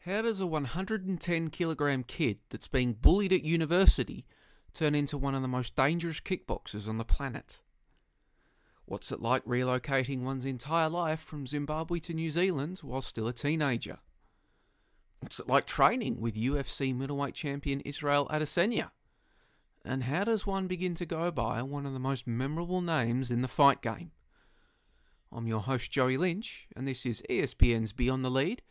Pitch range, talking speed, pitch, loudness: 125-165 Hz, 165 wpm, 140 Hz, -31 LUFS